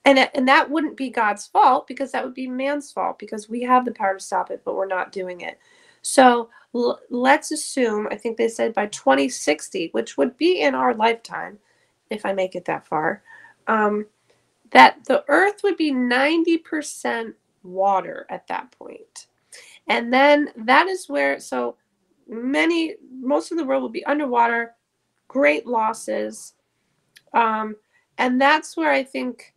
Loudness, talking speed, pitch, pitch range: -20 LUFS, 165 wpm, 260 Hz, 220-305 Hz